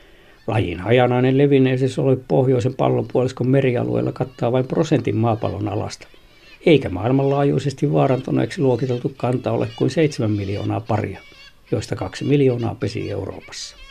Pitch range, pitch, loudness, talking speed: 105-135 Hz, 125 Hz, -20 LUFS, 115 wpm